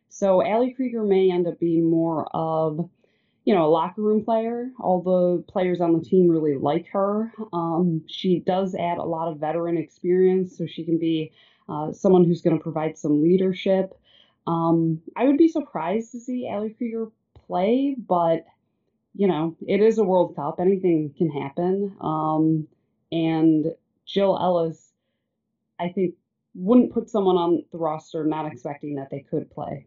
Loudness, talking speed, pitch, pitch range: -23 LUFS, 170 wpm, 175 Hz, 160-195 Hz